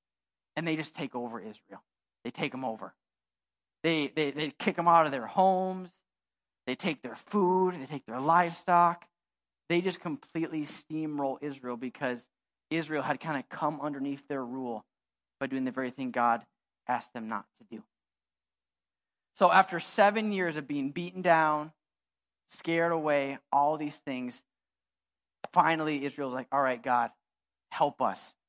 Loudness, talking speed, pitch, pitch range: -30 LUFS, 155 wpm, 145 Hz, 125-165 Hz